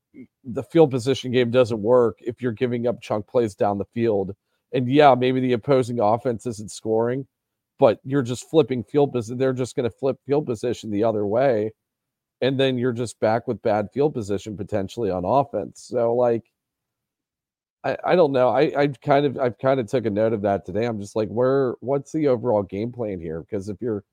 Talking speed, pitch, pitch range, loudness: 210 wpm, 120 Hz, 110-130 Hz, -22 LUFS